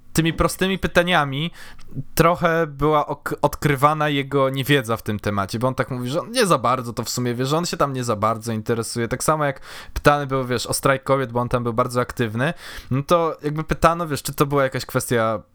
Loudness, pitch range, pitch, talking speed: -21 LUFS, 125-155 Hz, 135 Hz, 225 wpm